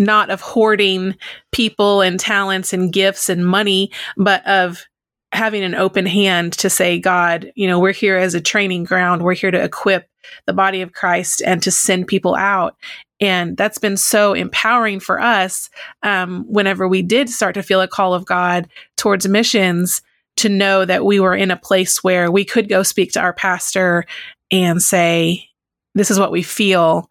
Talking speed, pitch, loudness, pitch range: 185 wpm, 190 Hz, -15 LUFS, 180-200 Hz